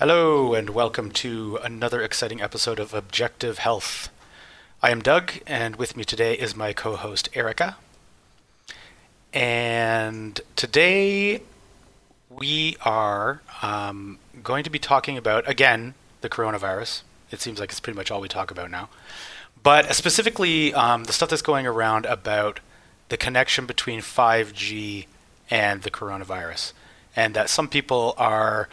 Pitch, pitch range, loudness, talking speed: 115 Hz, 105-140 Hz, -23 LUFS, 140 wpm